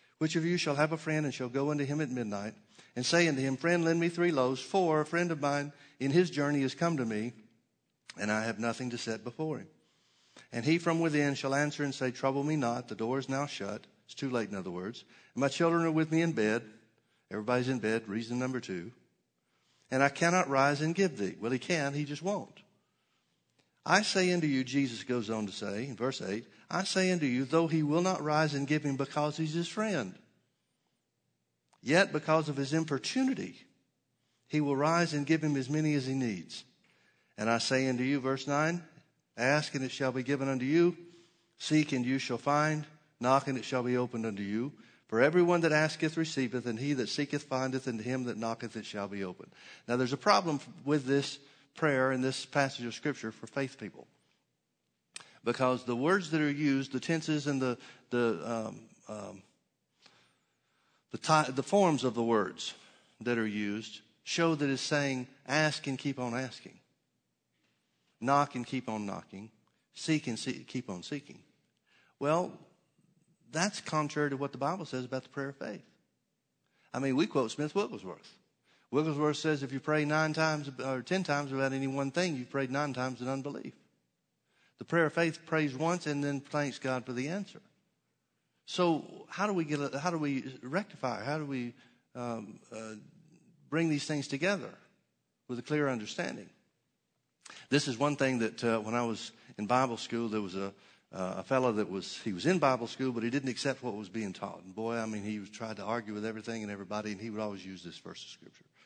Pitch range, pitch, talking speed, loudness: 120-155 Hz, 135 Hz, 205 wpm, -32 LUFS